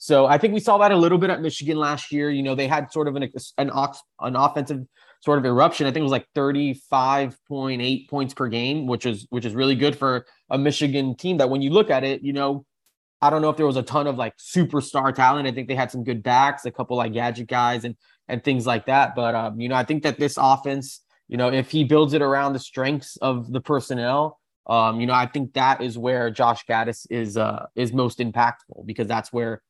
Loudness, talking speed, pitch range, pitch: -22 LUFS, 245 wpm, 125-145 Hz, 135 Hz